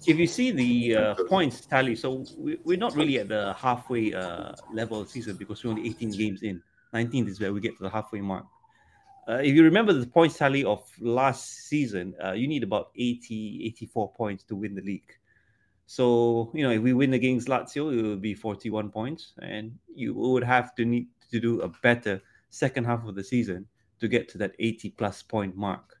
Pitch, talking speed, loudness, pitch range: 115 Hz, 210 wpm, -27 LUFS, 105-130 Hz